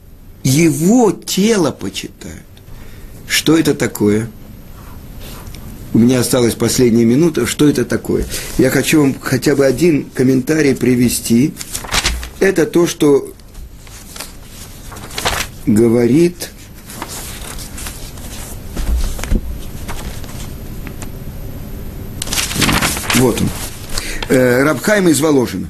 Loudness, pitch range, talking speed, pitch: -14 LUFS, 100-140 Hz, 70 wpm, 120 Hz